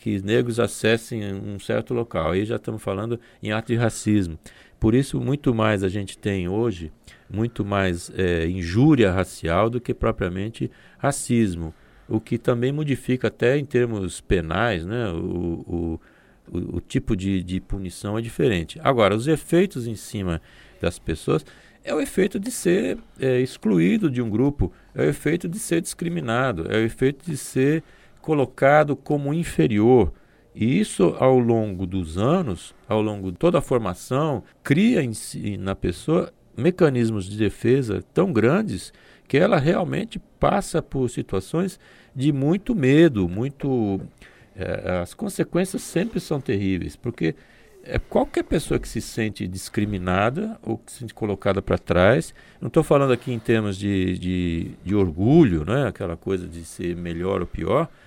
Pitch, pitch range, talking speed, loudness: 115 Hz, 95-140 Hz, 155 wpm, -23 LUFS